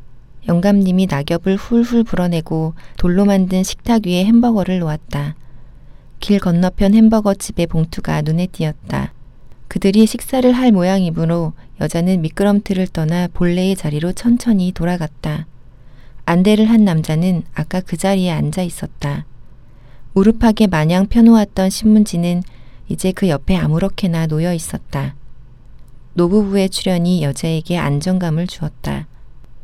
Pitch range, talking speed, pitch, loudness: 150-195 Hz, 295 characters per minute, 175 Hz, -16 LUFS